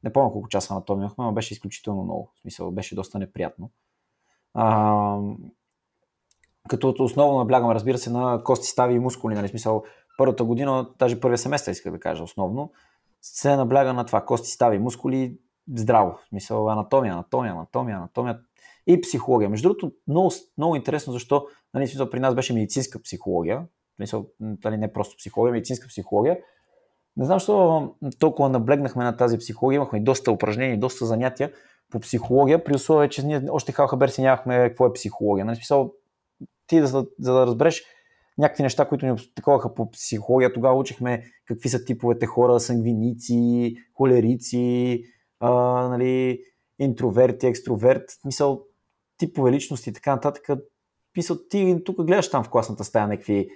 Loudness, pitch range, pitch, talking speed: -23 LUFS, 115-140 Hz, 125 Hz, 155 wpm